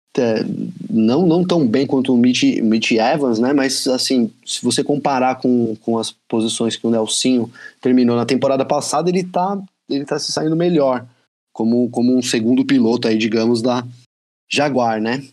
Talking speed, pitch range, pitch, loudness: 170 wpm, 115-140 Hz, 125 Hz, -17 LUFS